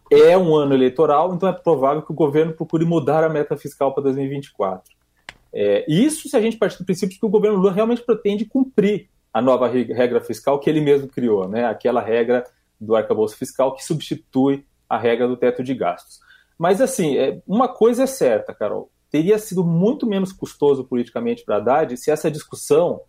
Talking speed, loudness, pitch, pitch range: 190 wpm, -19 LUFS, 155 Hz, 130-210 Hz